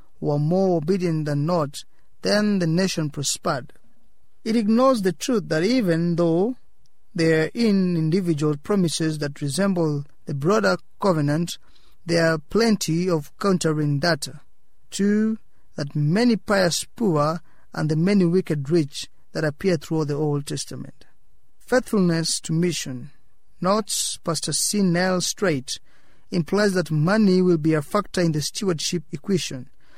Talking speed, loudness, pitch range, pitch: 135 wpm, -22 LUFS, 150-195 Hz, 170 Hz